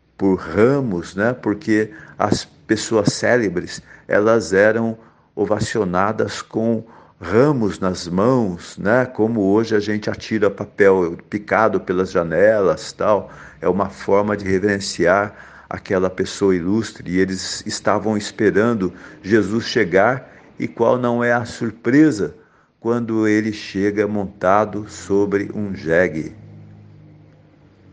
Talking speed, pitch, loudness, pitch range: 110 wpm, 105 Hz, -19 LUFS, 100-115 Hz